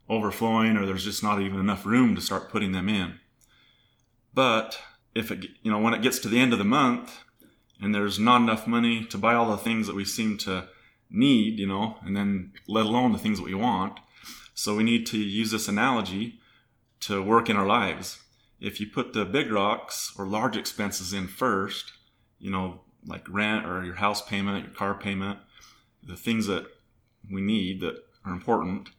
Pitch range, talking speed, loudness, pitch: 100-115 Hz, 195 wpm, -26 LUFS, 105 Hz